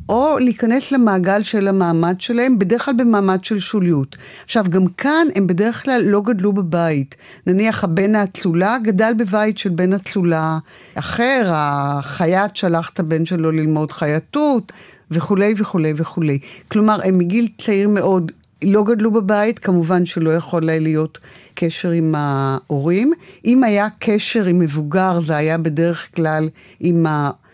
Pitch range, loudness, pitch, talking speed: 160-215 Hz, -17 LUFS, 185 Hz, 145 wpm